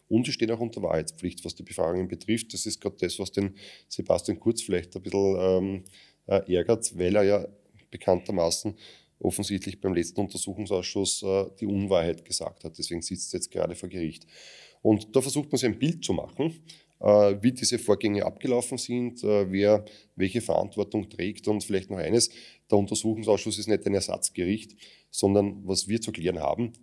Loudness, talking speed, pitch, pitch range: -27 LUFS, 175 wpm, 100 Hz, 95-110 Hz